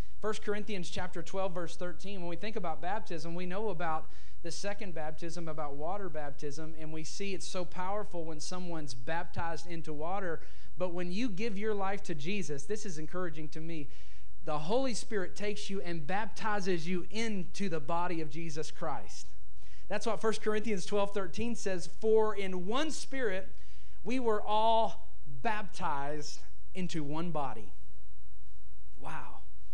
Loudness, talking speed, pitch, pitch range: -37 LUFS, 155 wpm, 175 Hz, 155-205 Hz